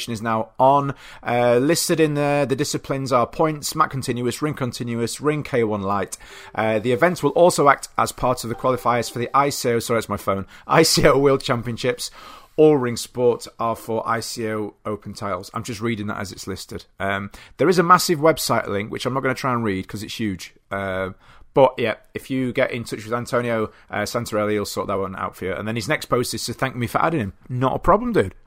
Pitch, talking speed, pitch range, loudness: 120 Hz, 225 wpm, 110-135 Hz, -21 LUFS